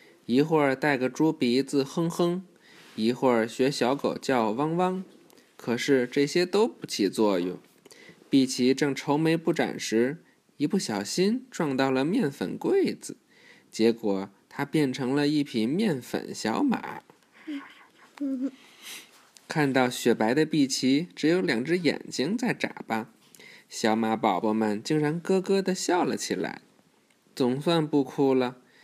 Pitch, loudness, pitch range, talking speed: 140 Hz, -26 LUFS, 125-170 Hz, 195 characters per minute